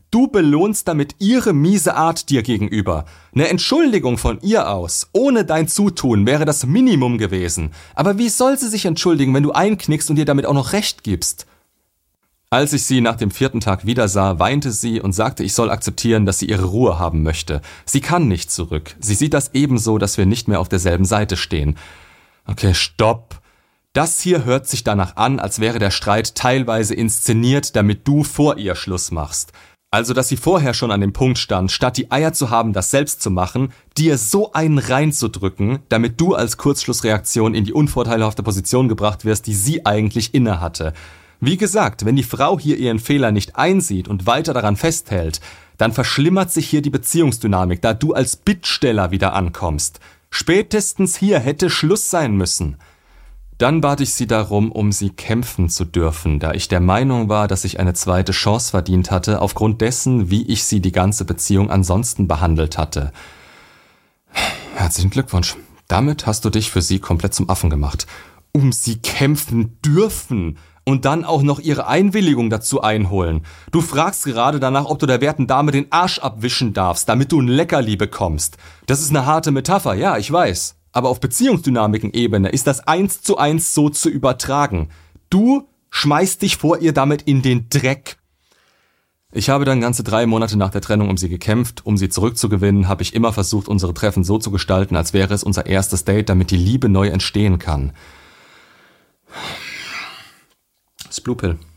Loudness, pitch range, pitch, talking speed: -17 LUFS, 95-145 Hz, 115 Hz, 180 wpm